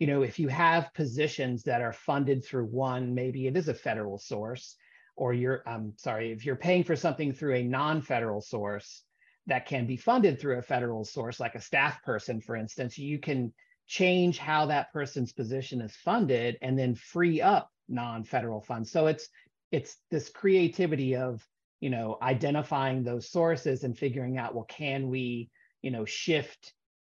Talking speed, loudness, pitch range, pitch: 175 wpm, -30 LUFS, 120-150 Hz, 130 Hz